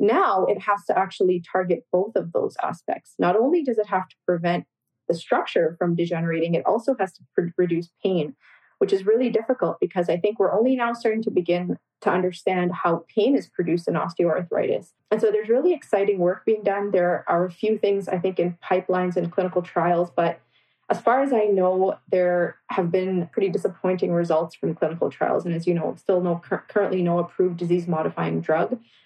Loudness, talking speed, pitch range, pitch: -23 LUFS, 195 wpm, 175-205 Hz, 185 Hz